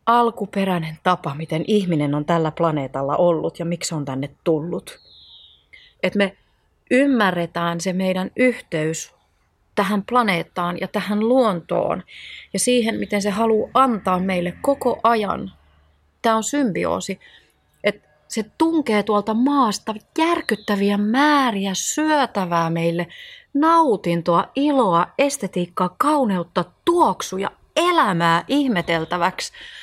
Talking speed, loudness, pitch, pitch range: 105 wpm, -20 LUFS, 195 Hz, 170-250 Hz